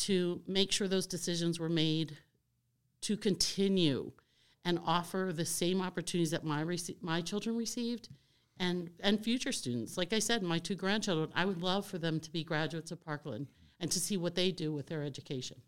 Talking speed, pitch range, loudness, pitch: 190 wpm, 155-190 Hz, -34 LUFS, 175 Hz